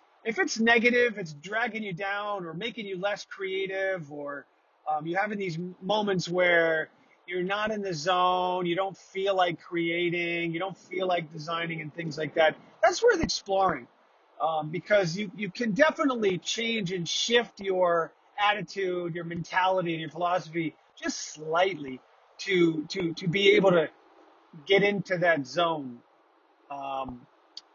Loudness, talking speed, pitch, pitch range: -27 LUFS, 150 wpm, 180 Hz, 165-200 Hz